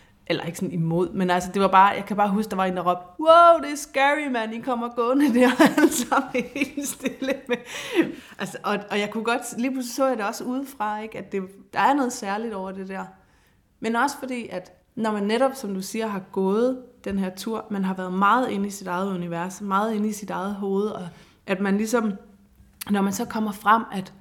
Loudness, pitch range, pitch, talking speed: -23 LUFS, 190-250 Hz, 210 Hz, 235 wpm